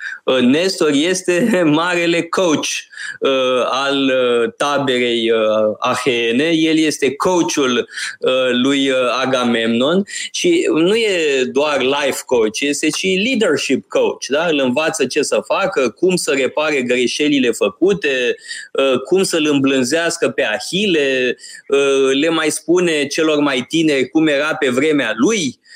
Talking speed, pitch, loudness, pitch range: 130 wpm, 155 Hz, -16 LUFS, 130-190 Hz